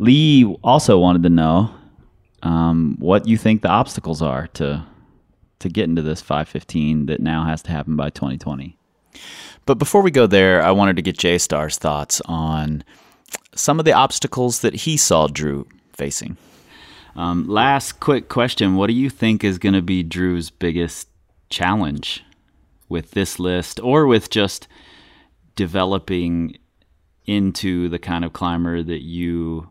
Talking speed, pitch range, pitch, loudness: 155 wpm, 80-95 Hz, 85 Hz, -18 LUFS